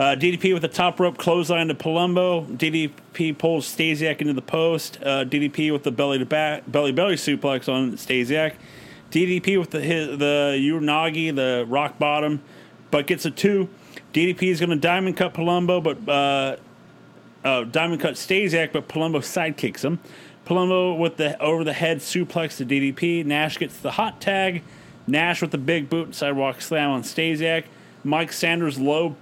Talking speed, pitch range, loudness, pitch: 170 wpm, 145-170 Hz, -22 LUFS, 160 Hz